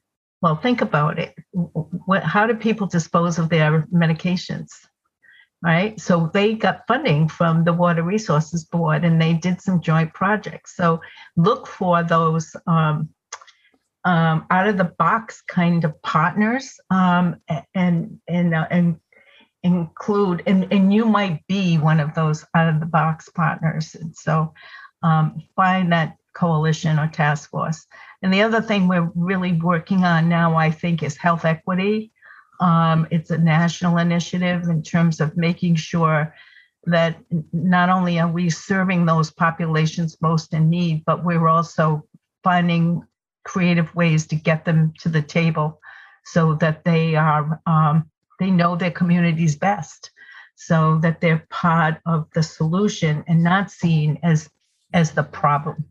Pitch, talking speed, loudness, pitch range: 170 Hz, 150 wpm, -20 LUFS, 160-180 Hz